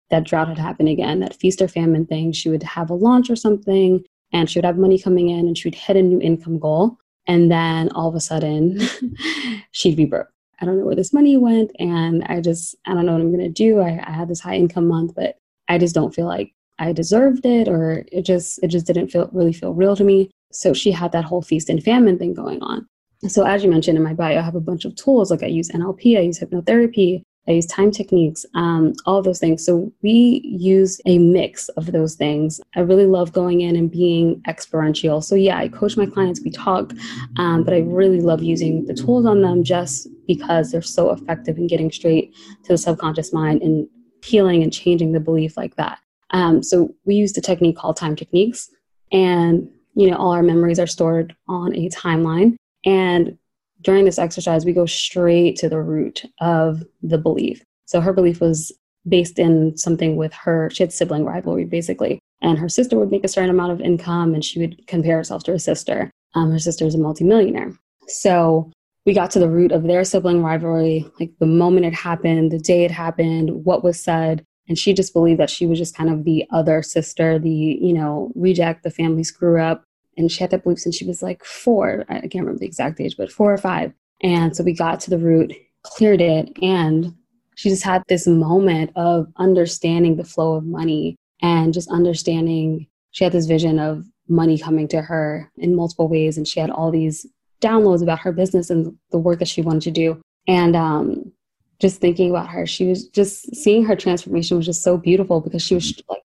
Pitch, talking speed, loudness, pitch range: 170 Hz, 220 wpm, -18 LUFS, 165-185 Hz